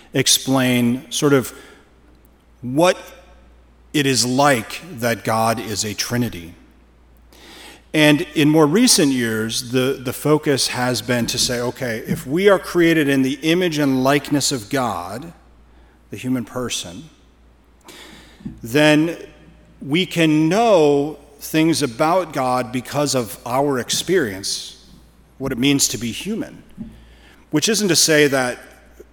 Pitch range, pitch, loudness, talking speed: 115-150 Hz, 130 Hz, -18 LUFS, 125 wpm